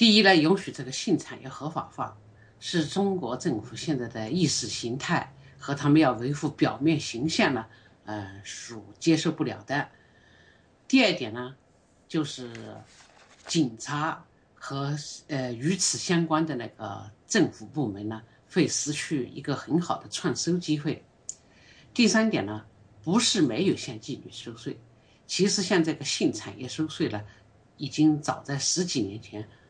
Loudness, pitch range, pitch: -27 LUFS, 110-160 Hz, 135 Hz